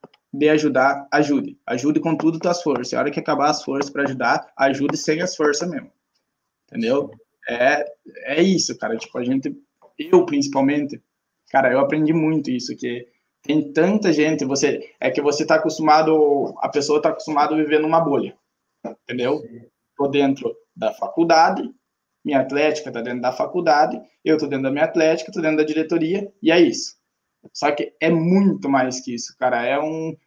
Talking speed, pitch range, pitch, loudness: 175 wpm, 145-170 Hz, 155 Hz, -20 LUFS